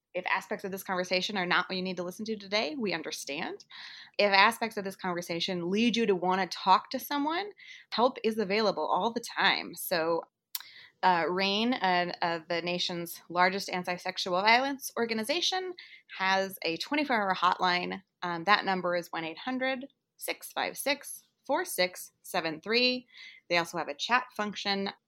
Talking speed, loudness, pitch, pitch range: 160 wpm, -29 LUFS, 195 Hz, 180-250 Hz